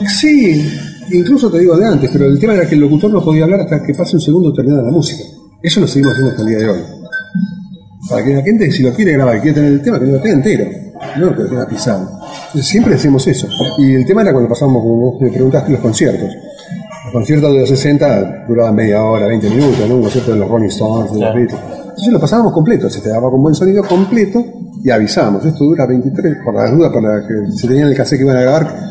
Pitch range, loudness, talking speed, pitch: 125-175 Hz, -11 LUFS, 245 wpm, 140 Hz